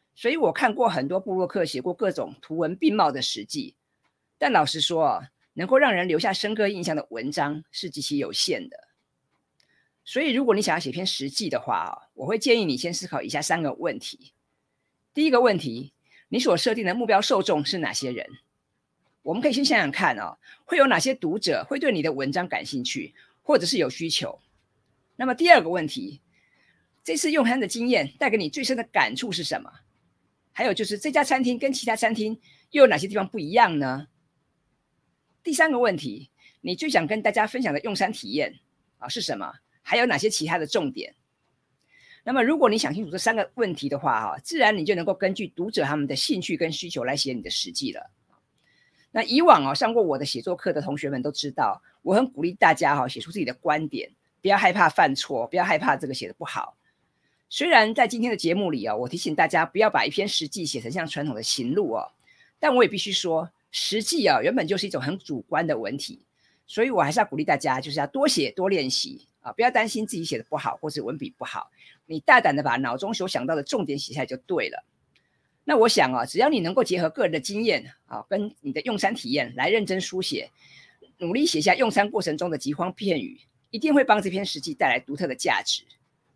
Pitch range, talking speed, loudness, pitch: 160-255 Hz, 315 characters per minute, -24 LUFS, 205 Hz